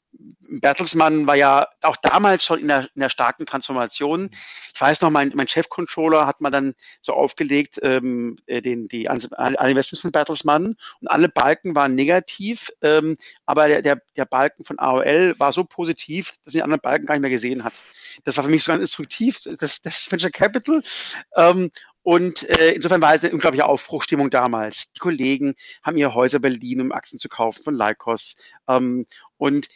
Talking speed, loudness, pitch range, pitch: 185 wpm, -19 LUFS, 135-165 Hz, 145 Hz